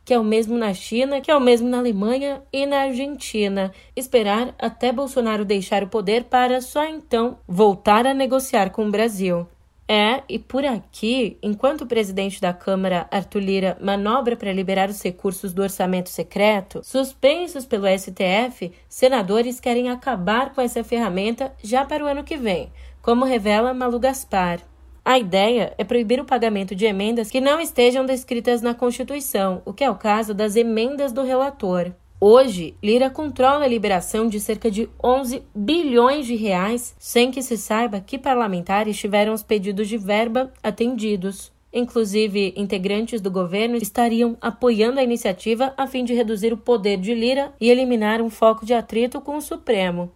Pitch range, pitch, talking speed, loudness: 205-255 Hz, 230 Hz, 165 wpm, -21 LUFS